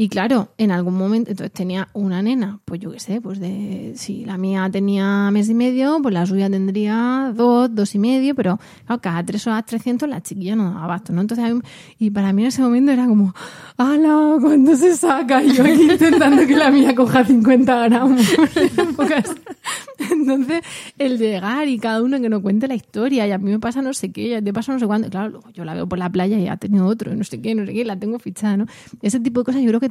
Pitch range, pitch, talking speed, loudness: 200-265 Hz, 230 Hz, 240 wpm, -17 LUFS